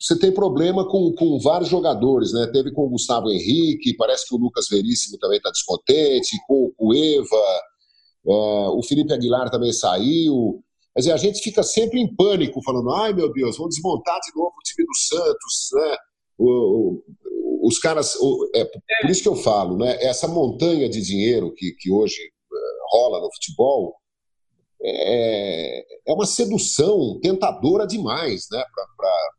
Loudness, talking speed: -20 LUFS, 170 wpm